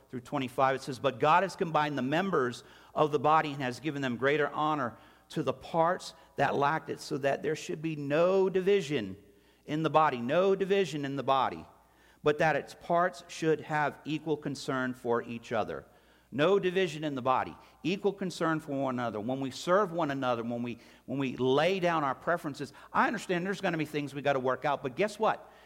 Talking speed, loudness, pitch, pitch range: 210 wpm, -30 LUFS, 150 Hz, 135-175 Hz